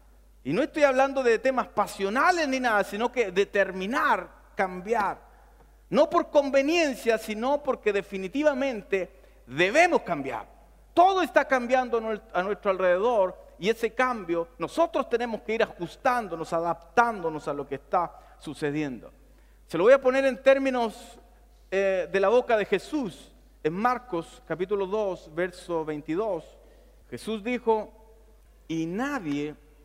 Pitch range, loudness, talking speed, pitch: 185-265 Hz, -26 LUFS, 130 wpm, 220 Hz